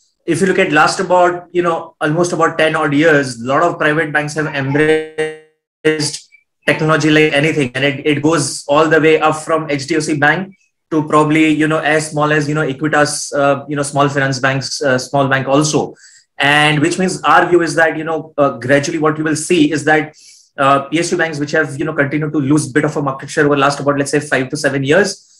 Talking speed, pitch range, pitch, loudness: 225 wpm, 145-160 Hz, 155 Hz, -14 LUFS